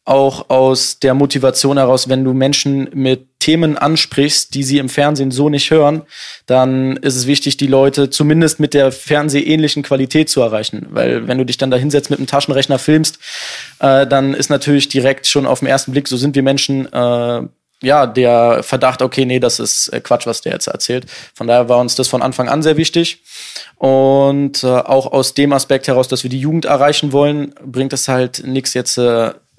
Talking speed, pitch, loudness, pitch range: 200 wpm, 135 Hz, -13 LUFS, 130-145 Hz